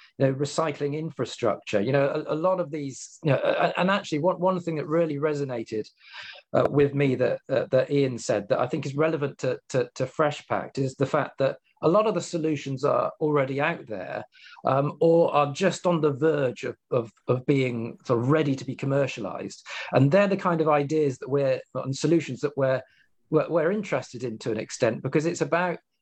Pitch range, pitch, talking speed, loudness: 135-160 Hz, 145 Hz, 210 wpm, -26 LUFS